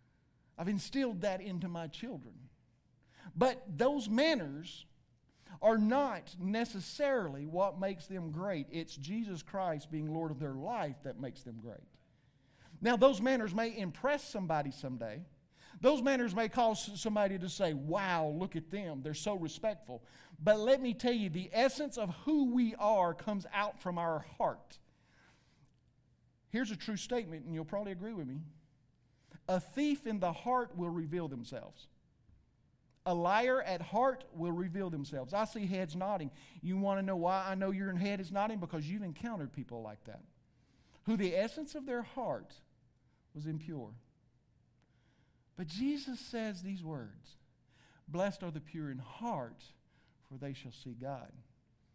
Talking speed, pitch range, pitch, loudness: 155 wpm, 150-215 Hz, 180 Hz, -36 LUFS